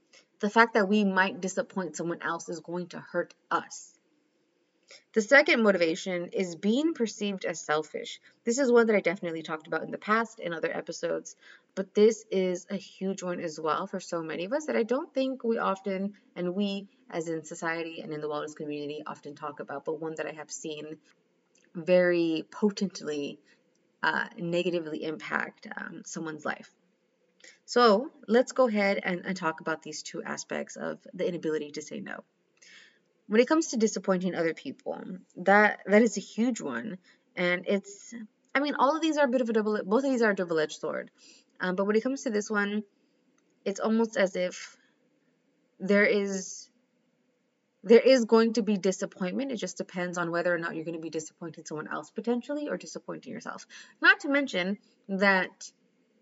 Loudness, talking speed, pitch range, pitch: -28 LUFS, 185 wpm, 170-235 Hz, 195 Hz